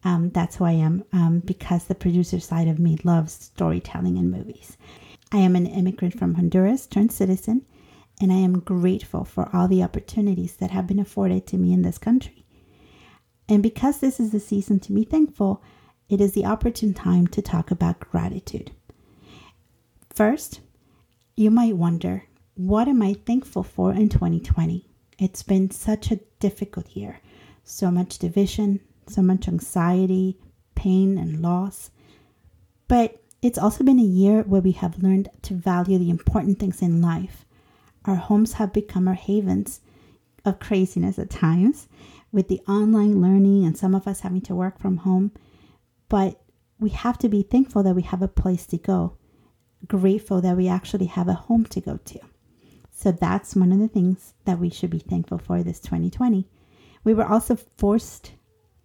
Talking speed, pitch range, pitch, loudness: 170 wpm, 175-205 Hz, 190 Hz, -22 LUFS